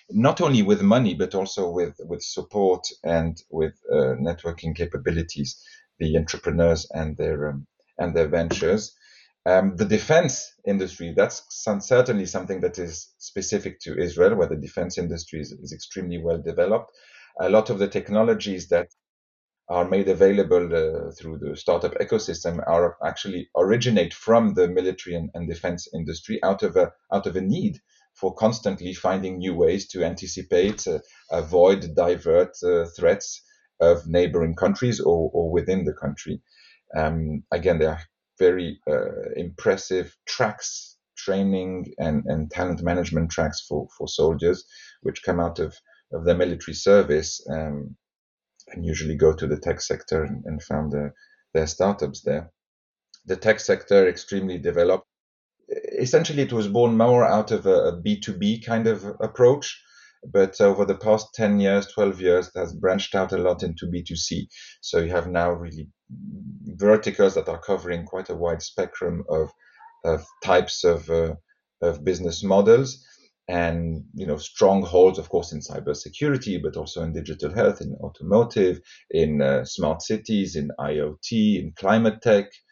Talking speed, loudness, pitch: 155 wpm, -23 LUFS, 95 Hz